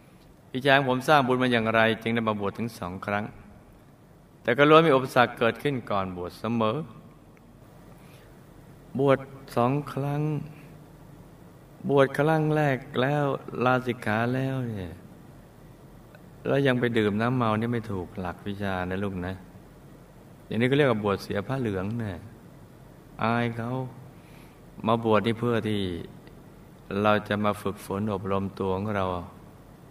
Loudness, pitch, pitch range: -26 LUFS, 115 Hz, 105-135 Hz